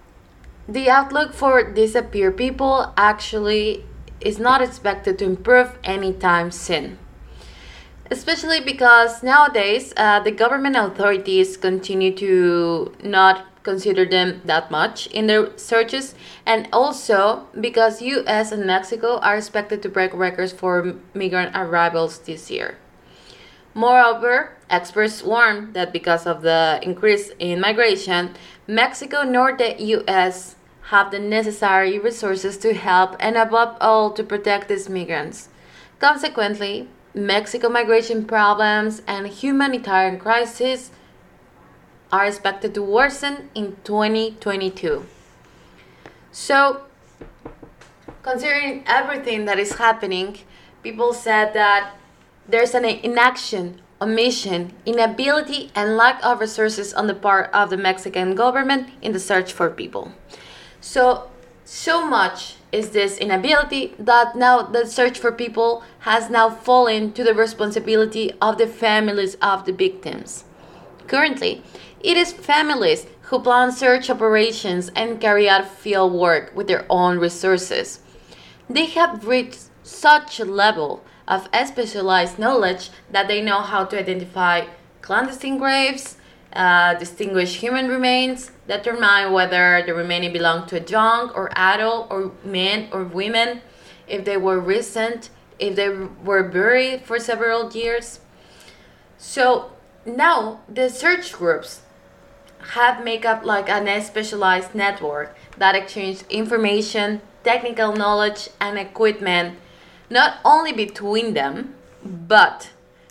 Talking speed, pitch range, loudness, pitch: 120 wpm, 190-240 Hz, -18 LUFS, 215 Hz